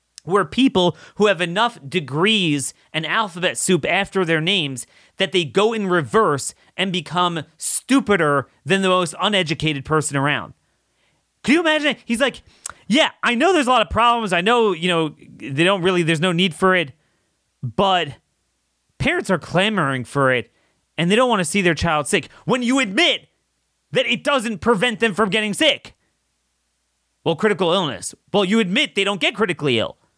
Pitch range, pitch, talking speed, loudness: 150-215 Hz, 185 Hz, 175 wpm, -19 LUFS